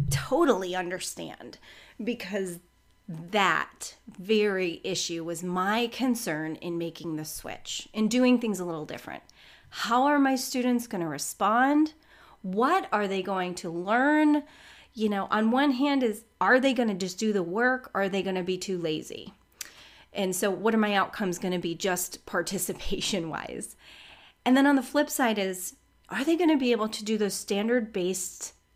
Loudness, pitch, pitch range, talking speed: -27 LUFS, 205 Hz, 185-250 Hz, 175 wpm